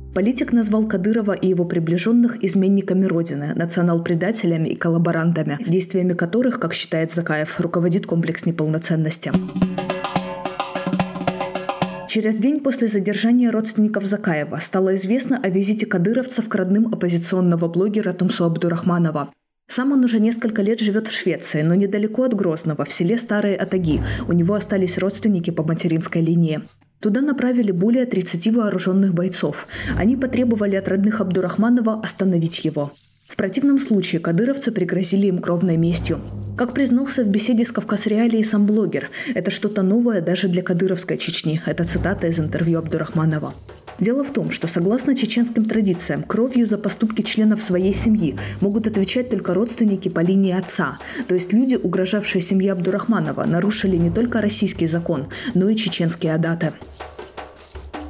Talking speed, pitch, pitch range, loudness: 140 wpm, 190 Hz, 170-220 Hz, -20 LUFS